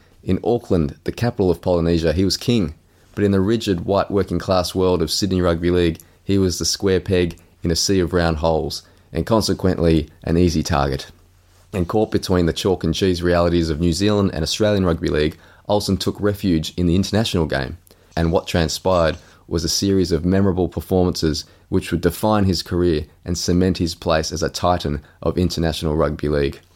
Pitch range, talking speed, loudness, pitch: 80-95 Hz, 190 wpm, -20 LUFS, 90 Hz